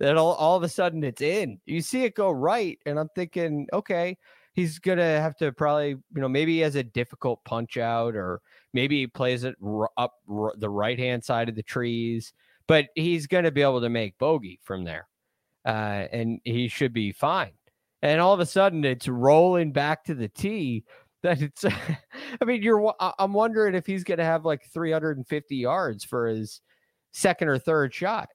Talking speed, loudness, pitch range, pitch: 195 wpm, -26 LUFS, 120-175 Hz, 145 Hz